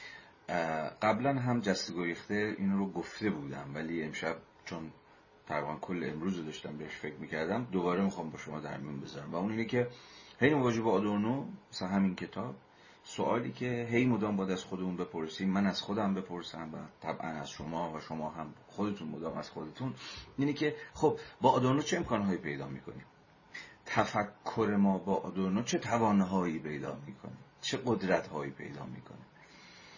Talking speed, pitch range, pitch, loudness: 160 wpm, 80-115 Hz, 95 Hz, -34 LUFS